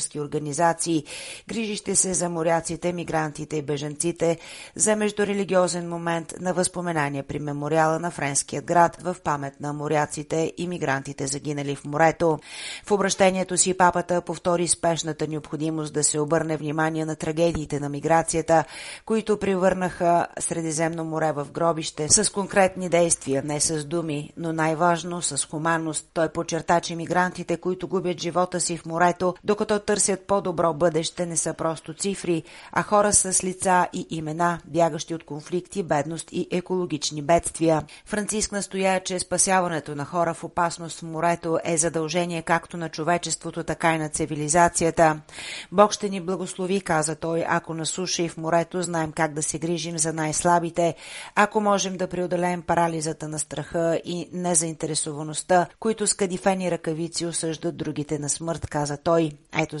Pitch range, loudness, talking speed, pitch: 155-180 Hz, -24 LUFS, 145 wpm, 170 Hz